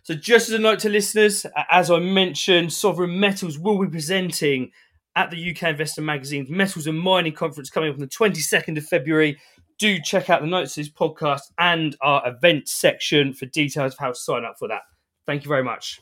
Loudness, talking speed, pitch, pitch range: -21 LUFS, 210 wpm, 165 Hz, 150-190 Hz